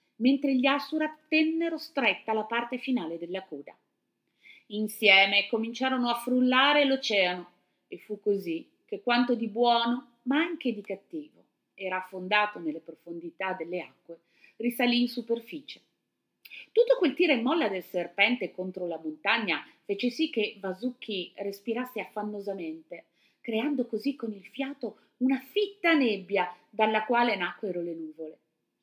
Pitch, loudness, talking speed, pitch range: 220 Hz, -28 LUFS, 135 wpm, 185-260 Hz